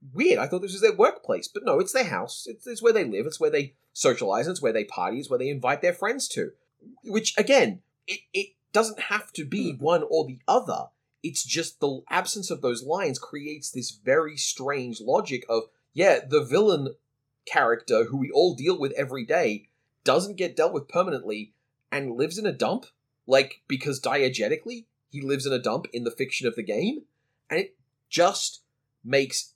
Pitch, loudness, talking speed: 165 Hz, -26 LUFS, 195 wpm